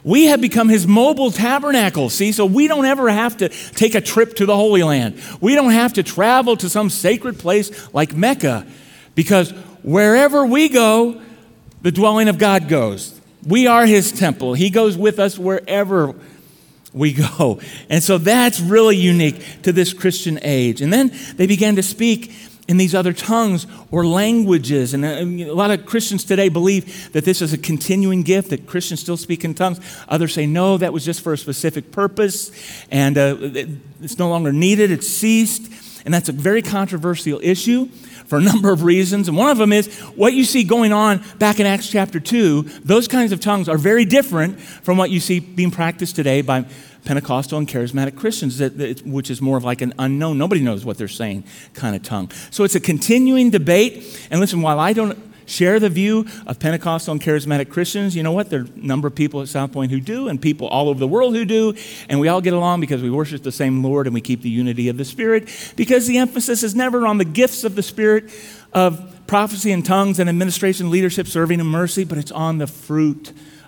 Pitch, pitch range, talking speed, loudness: 185 Hz, 150-215 Hz, 205 wpm, -17 LUFS